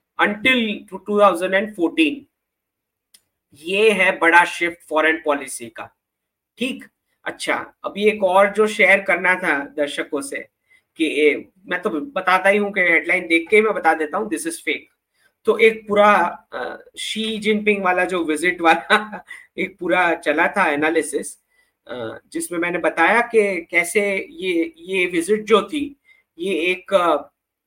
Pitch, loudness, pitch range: 195 Hz, -18 LUFS, 170-225 Hz